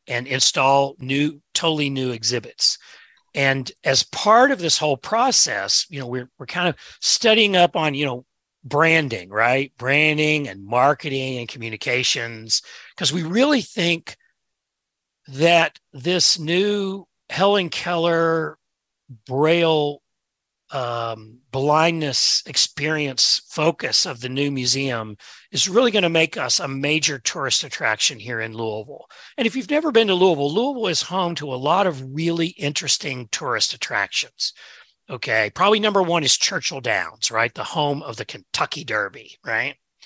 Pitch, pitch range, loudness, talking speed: 145 Hz, 130-170 Hz, -20 LUFS, 140 wpm